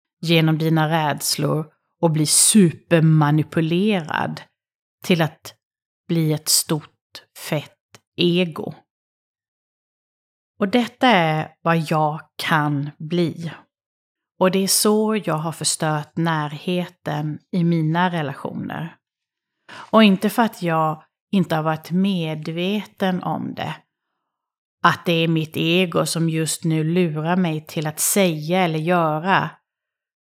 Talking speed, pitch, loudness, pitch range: 115 wpm, 165 Hz, -20 LUFS, 155-180 Hz